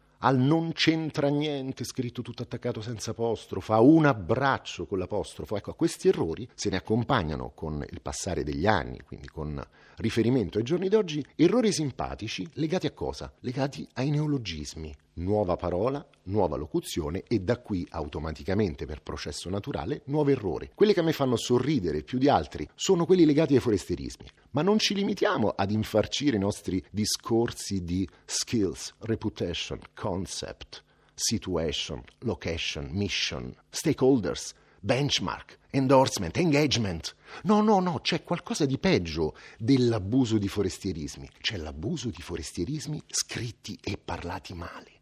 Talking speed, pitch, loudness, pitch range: 140 wpm, 115 Hz, -28 LUFS, 95-145 Hz